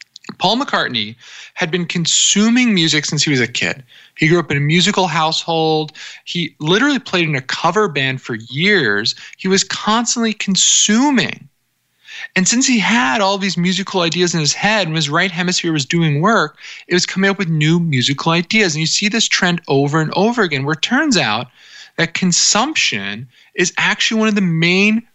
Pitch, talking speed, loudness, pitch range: 175 Hz, 185 wpm, -15 LUFS, 155-210 Hz